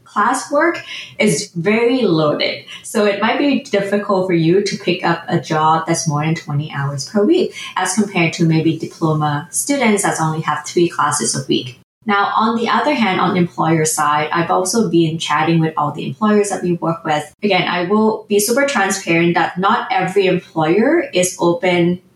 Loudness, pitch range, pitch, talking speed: -16 LUFS, 160-210 Hz, 180 Hz, 185 wpm